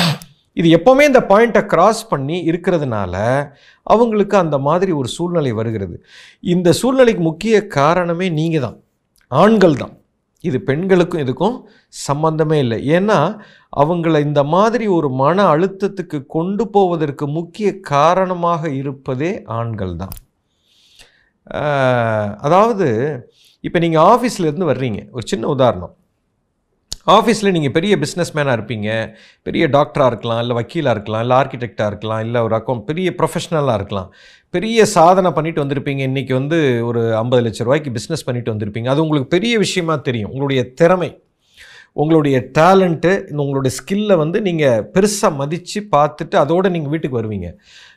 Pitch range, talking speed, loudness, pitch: 130-185 Hz, 130 wpm, -16 LUFS, 160 Hz